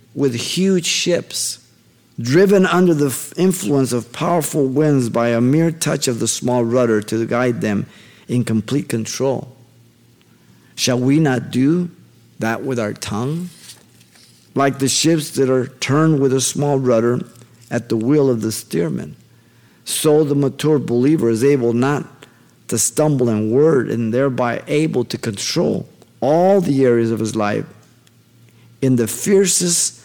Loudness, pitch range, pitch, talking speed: -17 LUFS, 120-150 Hz, 130 Hz, 145 wpm